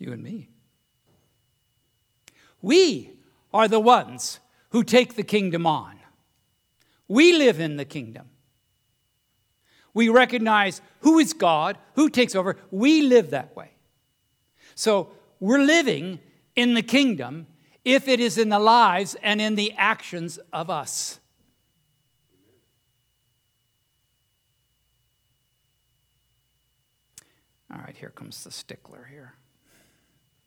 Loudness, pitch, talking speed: -21 LUFS, 165 Hz, 105 wpm